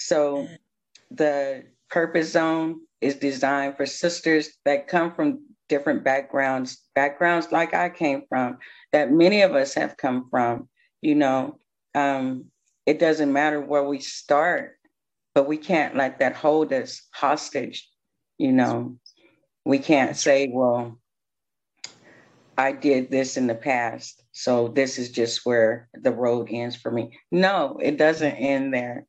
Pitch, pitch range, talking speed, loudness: 140 Hz, 125-160 Hz, 140 wpm, -23 LUFS